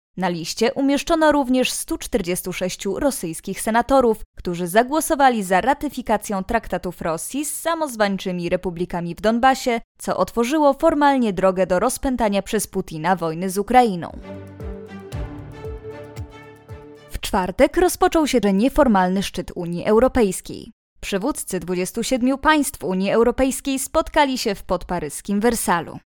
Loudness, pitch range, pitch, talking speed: -20 LUFS, 180-260 Hz, 205 Hz, 110 wpm